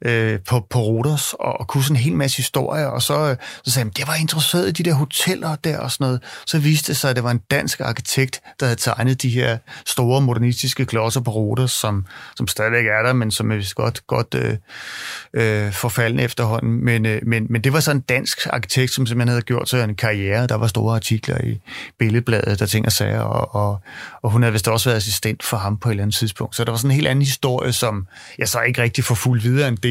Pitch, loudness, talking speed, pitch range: 120 Hz, -19 LUFS, 245 wpm, 110-135 Hz